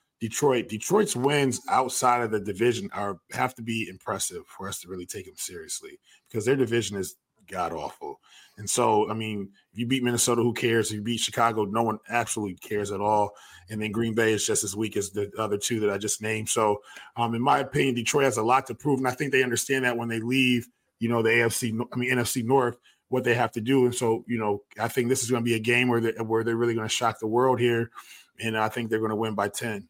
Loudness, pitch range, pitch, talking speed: -26 LUFS, 110-125 Hz, 115 Hz, 255 wpm